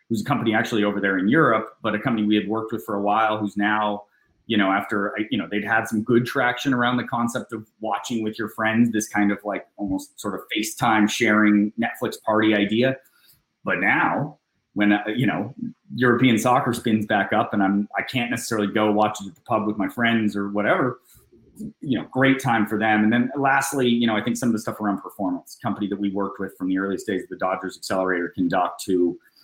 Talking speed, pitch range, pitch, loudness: 225 wpm, 100-115 Hz, 105 Hz, -22 LUFS